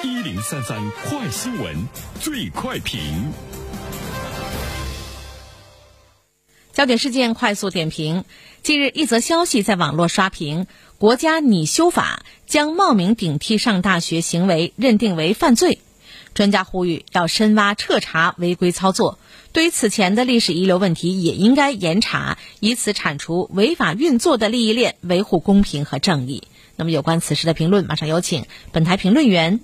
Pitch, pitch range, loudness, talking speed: 185 Hz, 160-225 Hz, -18 LUFS, 235 characters per minute